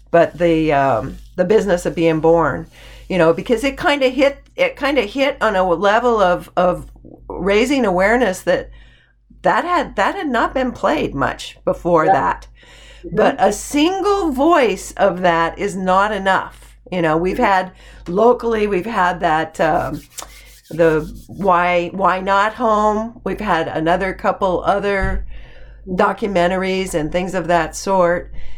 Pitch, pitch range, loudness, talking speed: 185 Hz, 175-220 Hz, -17 LUFS, 150 wpm